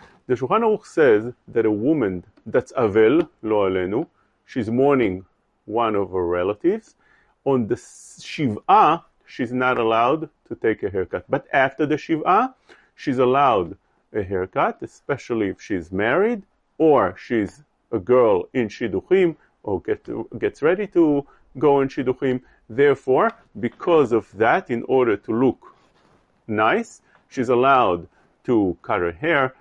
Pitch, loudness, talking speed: 140 Hz, -21 LUFS, 135 wpm